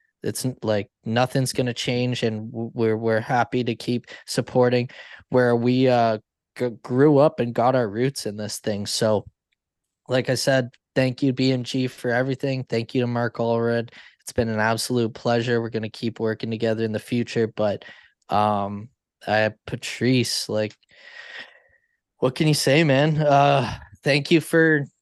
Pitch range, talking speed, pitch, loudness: 110-130 Hz, 165 wpm, 120 Hz, -22 LUFS